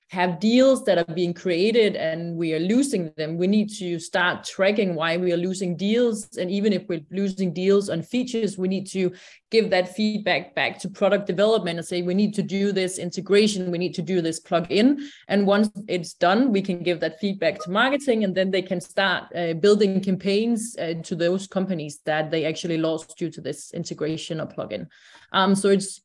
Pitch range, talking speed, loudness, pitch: 175-205 Hz, 205 wpm, -23 LUFS, 190 Hz